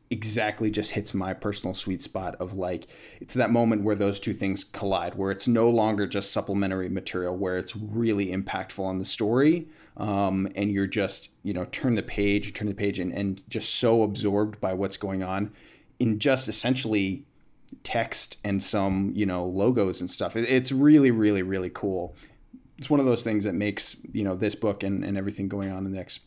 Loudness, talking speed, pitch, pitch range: -27 LUFS, 200 wpm, 100 Hz, 95-110 Hz